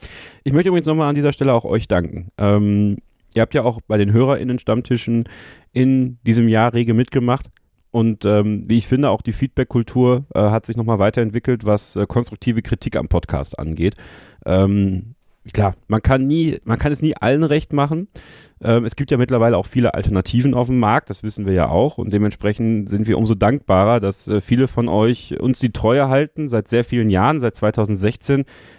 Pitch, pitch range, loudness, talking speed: 115 Hz, 105-130 Hz, -18 LUFS, 190 wpm